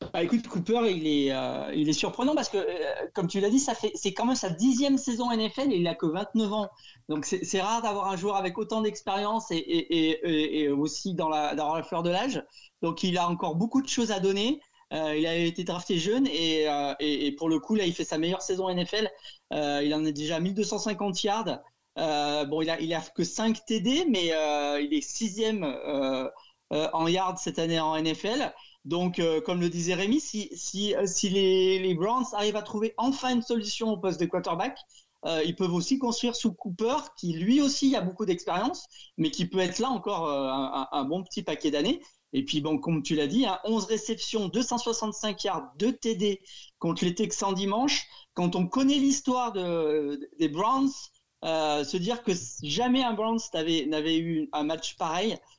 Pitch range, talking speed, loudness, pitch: 160-230 Hz, 215 wpm, -28 LUFS, 190 Hz